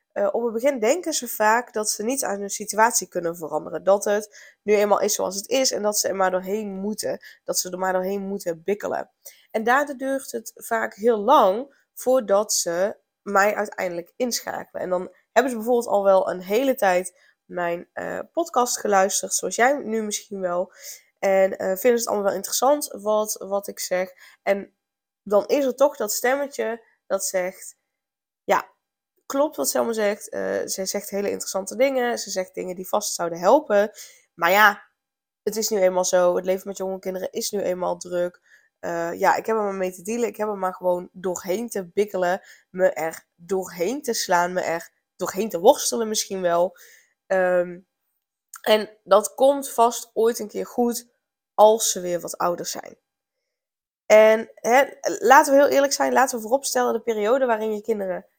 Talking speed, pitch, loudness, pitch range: 185 wpm, 205 Hz, -22 LUFS, 185-235 Hz